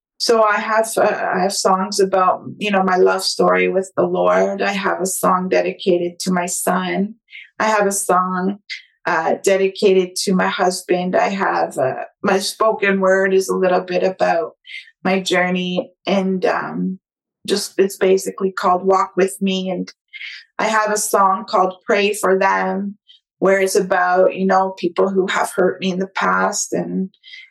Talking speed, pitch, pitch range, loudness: 170 wpm, 190 Hz, 185-200 Hz, -17 LUFS